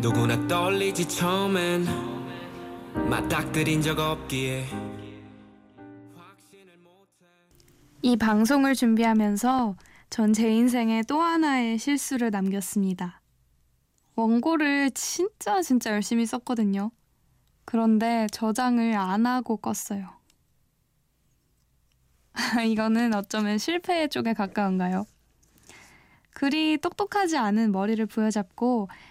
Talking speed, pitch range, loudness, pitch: 190 characters per minute, 180-245 Hz, -25 LUFS, 220 Hz